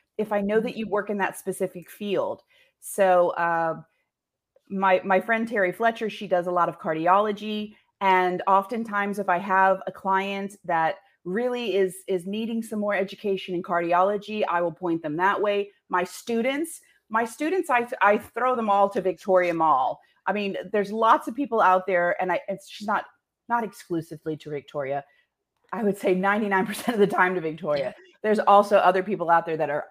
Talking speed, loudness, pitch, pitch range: 185 wpm, -24 LUFS, 195 Hz, 180-215 Hz